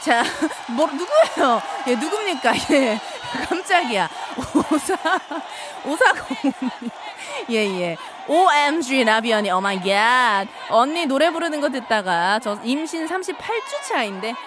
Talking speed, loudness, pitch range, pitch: 225 characters per minute, -20 LUFS, 225-335 Hz, 285 Hz